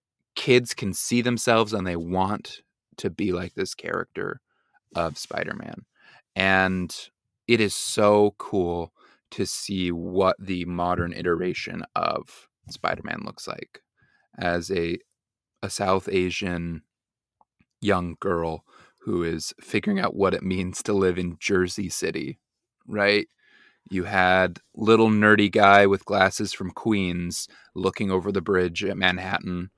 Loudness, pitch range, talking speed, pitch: -24 LUFS, 90-105 Hz, 130 wpm, 95 Hz